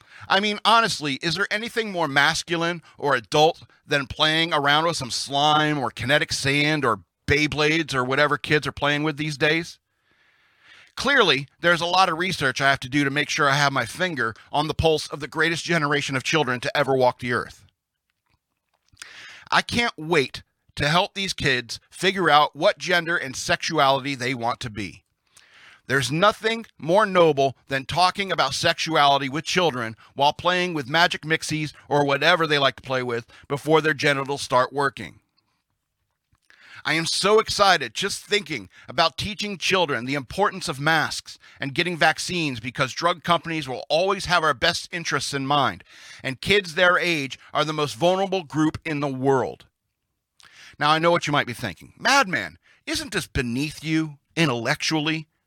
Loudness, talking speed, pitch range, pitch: -22 LUFS, 170 wpm, 135-170 Hz, 150 Hz